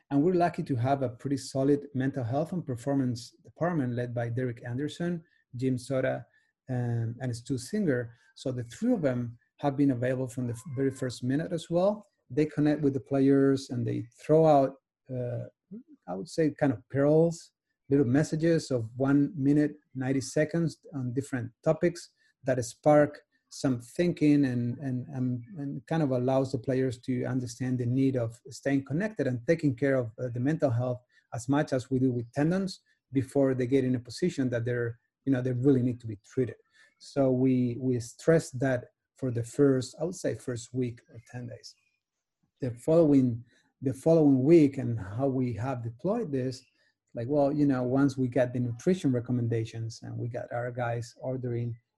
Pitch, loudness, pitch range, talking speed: 130 Hz, -29 LUFS, 125-145 Hz, 180 wpm